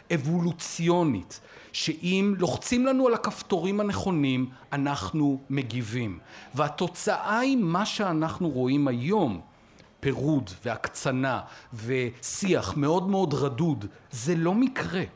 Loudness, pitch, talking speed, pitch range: -27 LUFS, 160 Hz, 95 wpm, 130-190 Hz